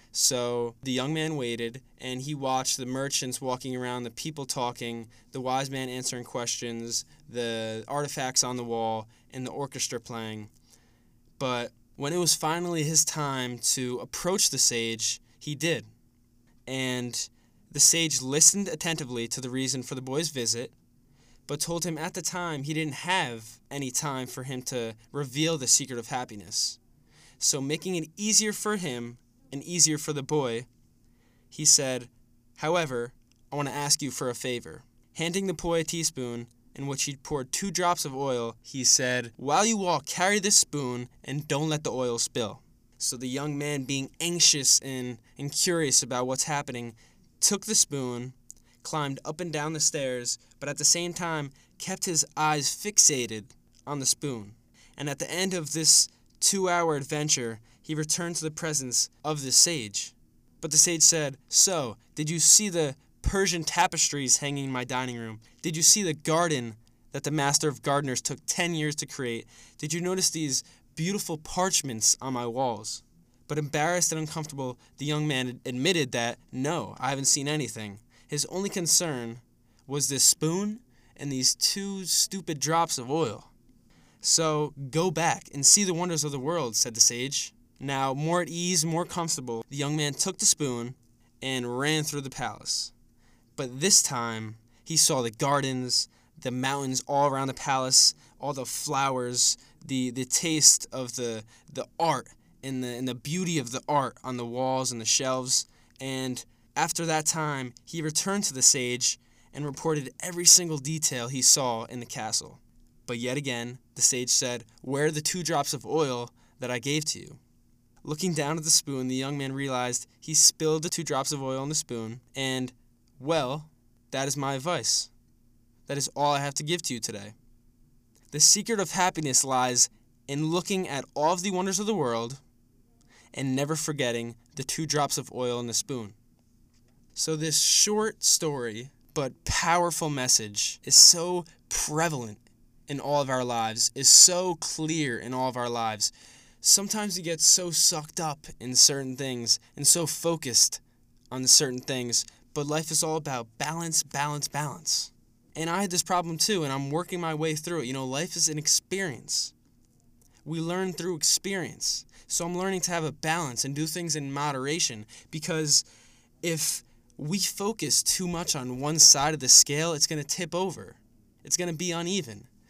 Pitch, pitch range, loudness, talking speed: 135 Hz, 120-160 Hz, -25 LUFS, 175 wpm